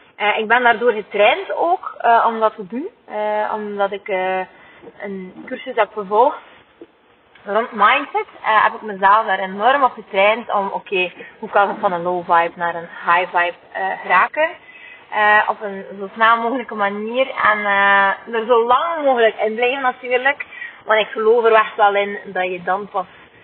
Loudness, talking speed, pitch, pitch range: -17 LUFS, 180 wpm, 215 Hz, 200-245 Hz